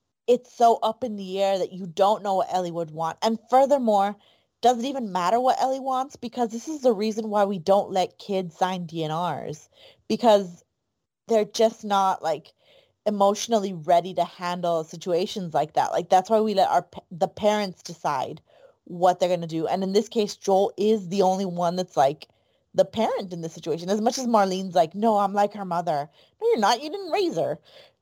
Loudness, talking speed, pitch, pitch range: -24 LUFS, 200 wpm, 200 Hz, 180-225 Hz